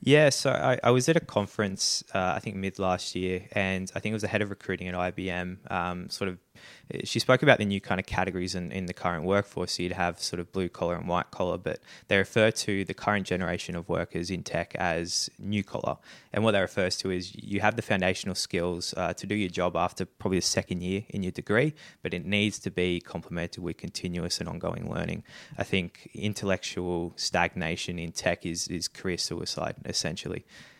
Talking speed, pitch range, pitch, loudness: 215 wpm, 90-105 Hz, 95 Hz, -29 LUFS